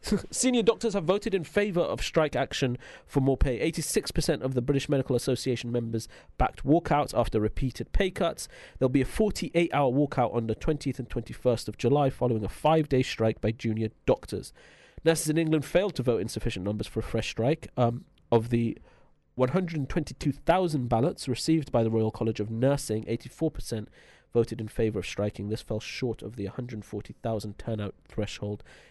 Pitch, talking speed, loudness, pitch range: 125 Hz, 175 wpm, -28 LUFS, 110-155 Hz